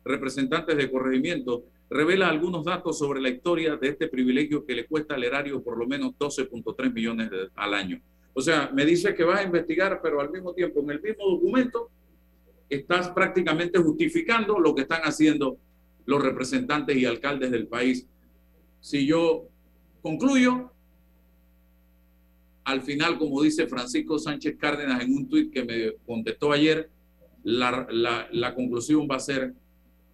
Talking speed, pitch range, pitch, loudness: 155 wpm, 115-160 Hz, 135 Hz, -26 LUFS